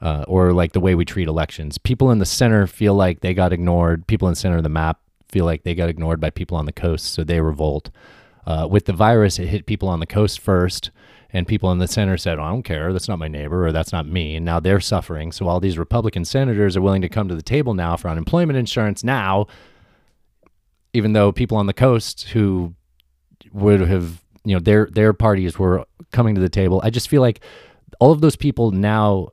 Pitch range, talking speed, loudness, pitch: 85-105 Hz, 235 wpm, -19 LUFS, 95 Hz